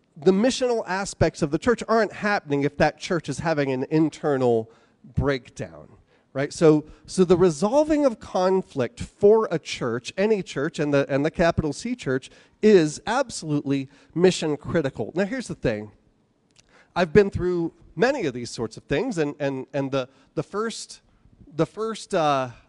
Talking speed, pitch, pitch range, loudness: 160 wpm, 160 Hz, 135-195 Hz, -23 LUFS